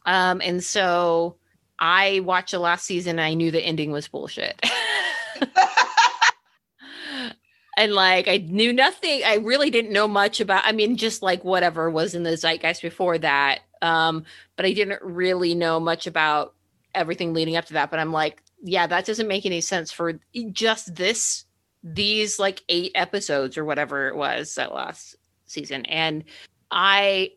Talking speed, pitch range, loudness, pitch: 165 wpm, 165-205 Hz, -22 LUFS, 180 Hz